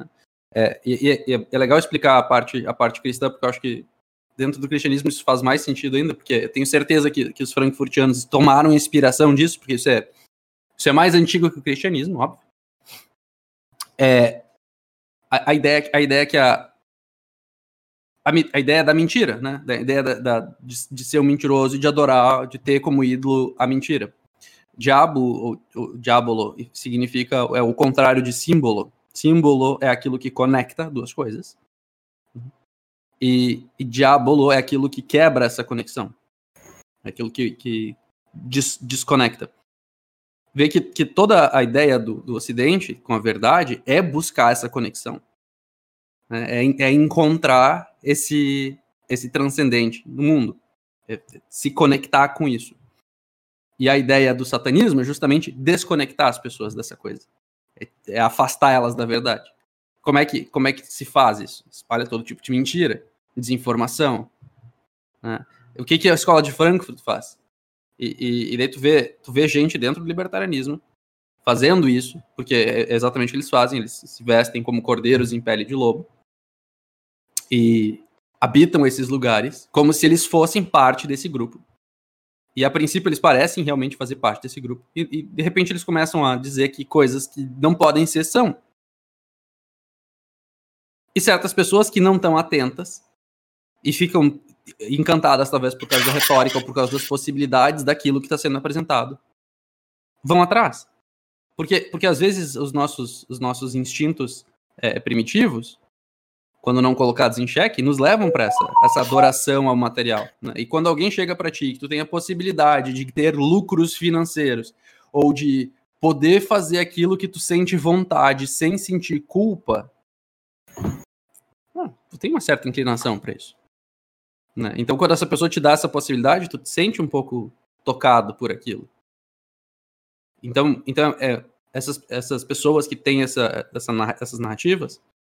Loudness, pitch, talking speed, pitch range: -19 LUFS, 135 Hz, 160 wpm, 125-155 Hz